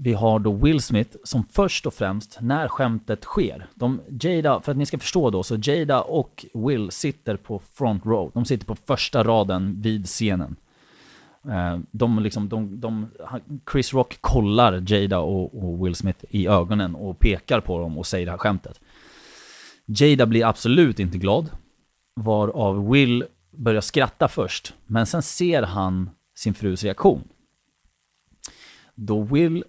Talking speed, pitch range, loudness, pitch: 155 wpm, 95-125 Hz, -22 LUFS, 110 Hz